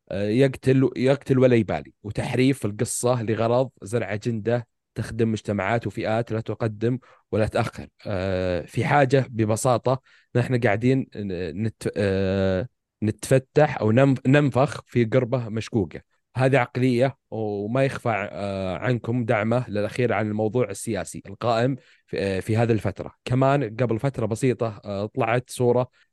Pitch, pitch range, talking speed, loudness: 115 Hz, 105-130 Hz, 110 wpm, -24 LUFS